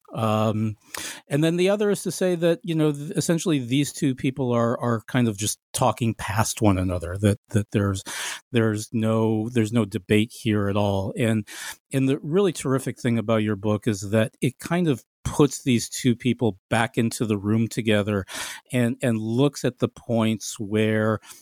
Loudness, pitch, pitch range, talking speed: -24 LUFS, 115 Hz, 110-135 Hz, 180 wpm